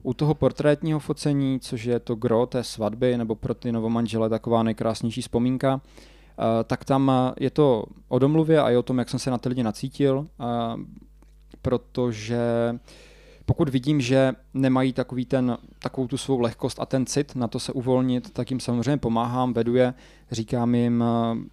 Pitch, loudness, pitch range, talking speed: 125 Hz, -24 LUFS, 120-135 Hz, 165 wpm